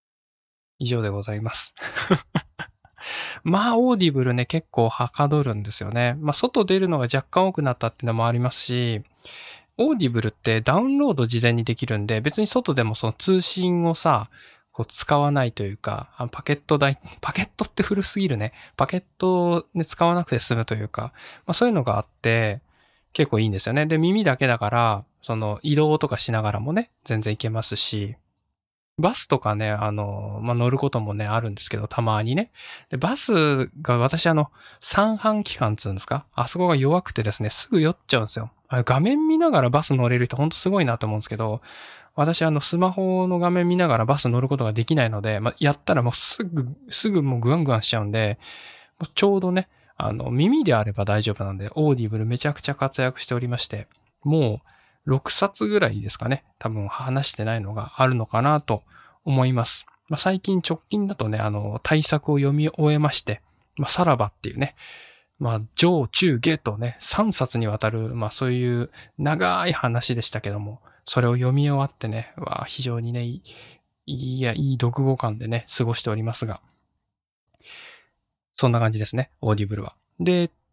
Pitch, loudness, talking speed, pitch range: 125 Hz, -23 LUFS, 370 characters per minute, 110-155 Hz